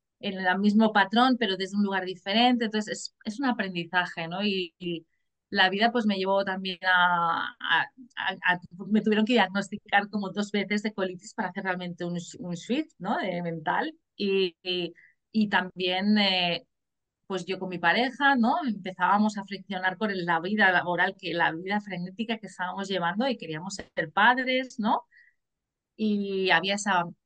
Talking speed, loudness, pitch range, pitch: 175 wpm, -27 LUFS, 180-215 Hz, 195 Hz